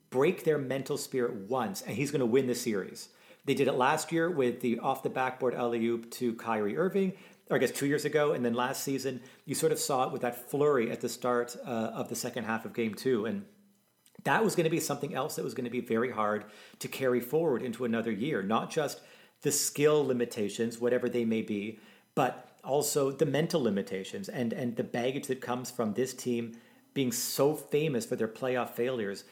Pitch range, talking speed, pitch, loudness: 115-145 Hz, 215 wpm, 125 Hz, -31 LUFS